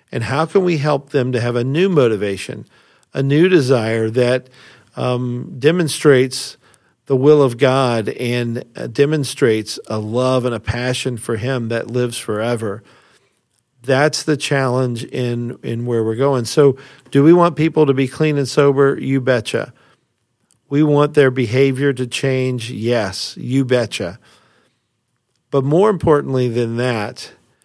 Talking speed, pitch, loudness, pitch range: 150 wpm, 130 Hz, -17 LUFS, 120-140 Hz